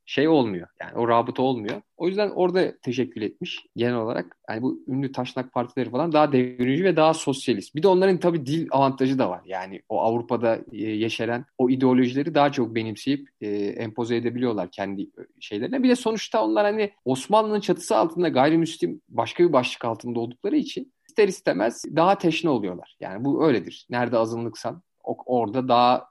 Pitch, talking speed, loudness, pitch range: 130 Hz, 165 wpm, -24 LUFS, 120-165 Hz